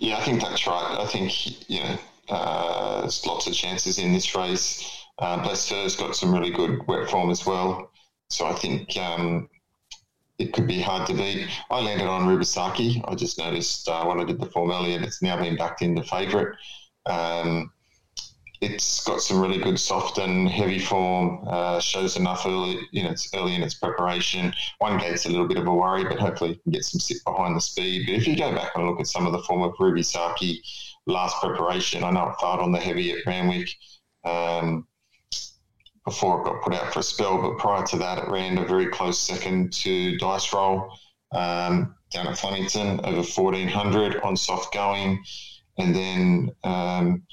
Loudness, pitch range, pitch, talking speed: -25 LUFS, 90-100 Hz, 90 Hz, 200 wpm